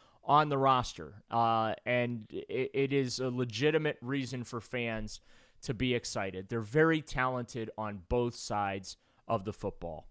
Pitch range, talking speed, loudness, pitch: 110-130 Hz, 150 wpm, -33 LUFS, 120 Hz